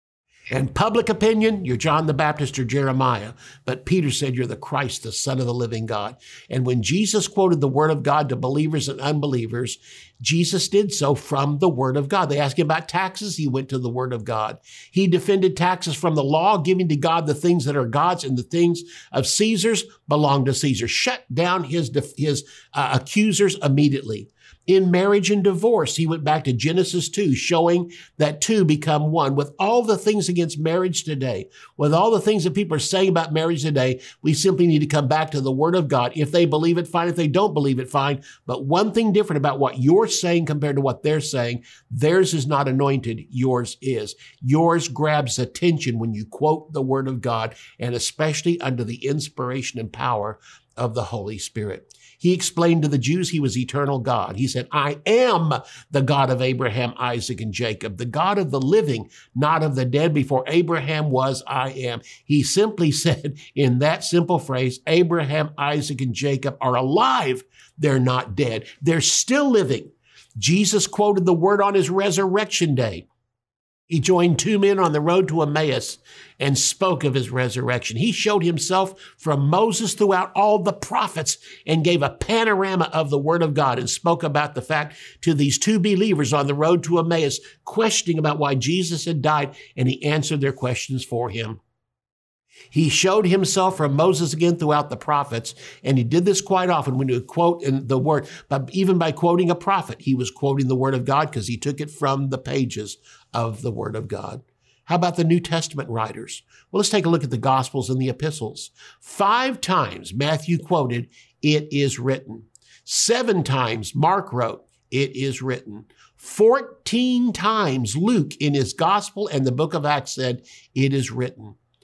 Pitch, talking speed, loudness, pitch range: 150 Hz, 190 wpm, -21 LUFS, 130-175 Hz